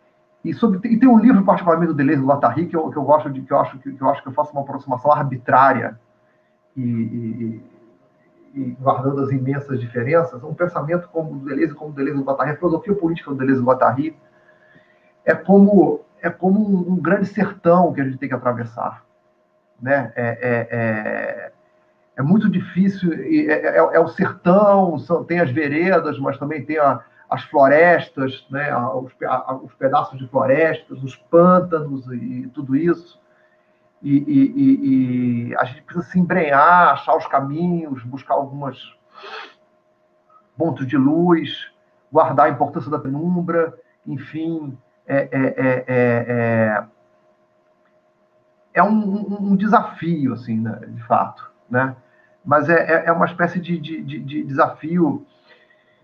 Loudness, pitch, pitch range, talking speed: -18 LUFS, 140 Hz, 125-170 Hz, 155 wpm